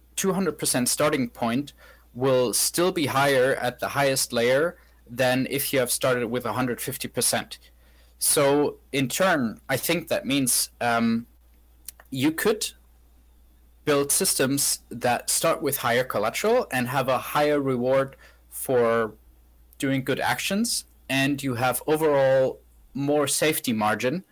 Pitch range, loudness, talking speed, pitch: 105-145 Hz, -24 LUFS, 125 wpm, 135 Hz